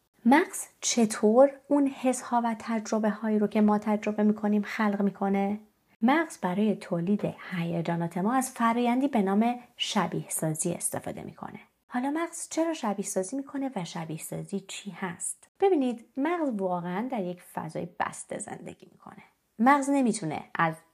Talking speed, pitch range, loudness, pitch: 155 wpm, 190-255 Hz, -28 LUFS, 210 Hz